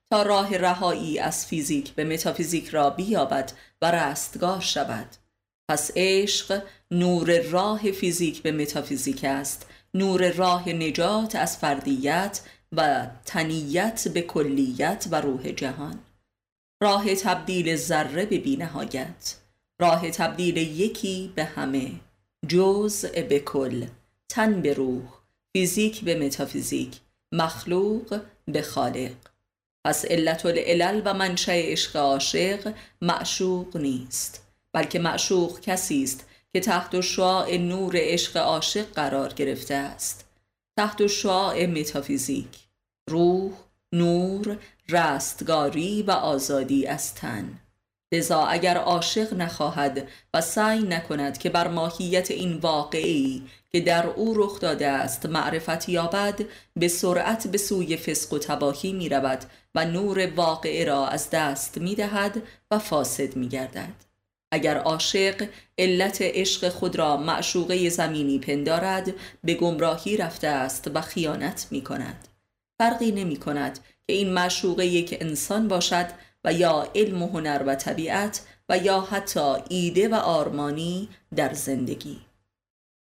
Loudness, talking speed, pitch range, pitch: -25 LUFS, 125 wpm, 140-190 Hz, 170 Hz